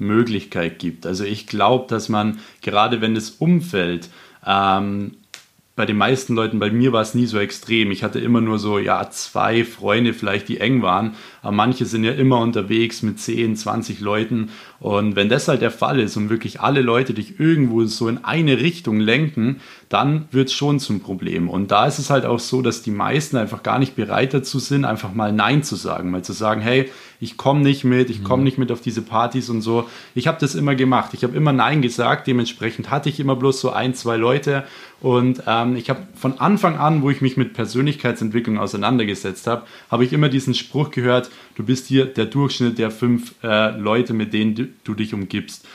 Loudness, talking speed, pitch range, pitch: -19 LUFS, 210 wpm, 110-130 Hz, 120 Hz